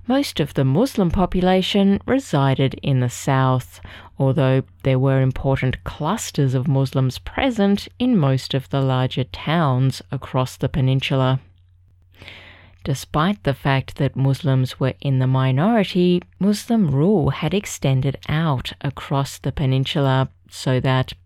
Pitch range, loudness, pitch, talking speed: 130-155 Hz, -20 LUFS, 135 Hz, 125 wpm